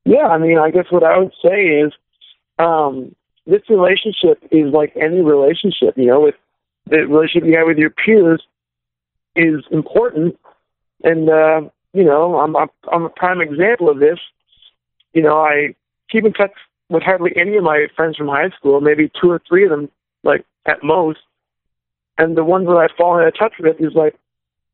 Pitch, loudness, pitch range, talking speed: 160 Hz, -14 LUFS, 150-180 Hz, 185 wpm